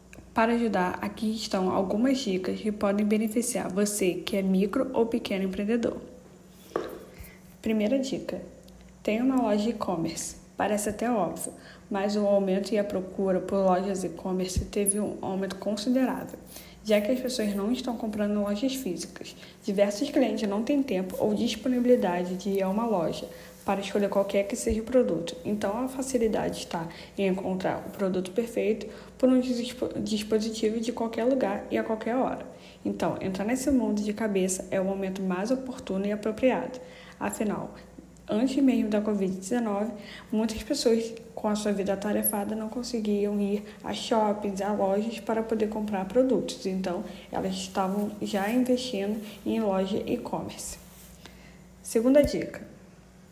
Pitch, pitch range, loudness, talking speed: 210 Hz, 195-230 Hz, -28 LUFS, 150 wpm